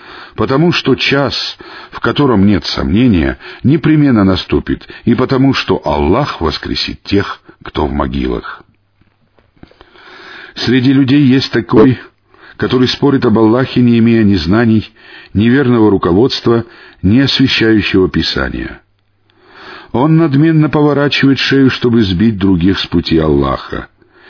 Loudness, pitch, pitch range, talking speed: -11 LUFS, 115 Hz, 100-135 Hz, 115 wpm